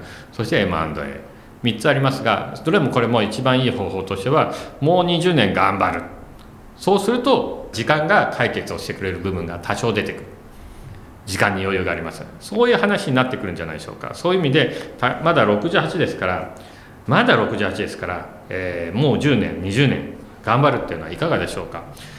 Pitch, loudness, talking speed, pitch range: 115 Hz, -20 LUFS, 355 characters per minute, 95-145 Hz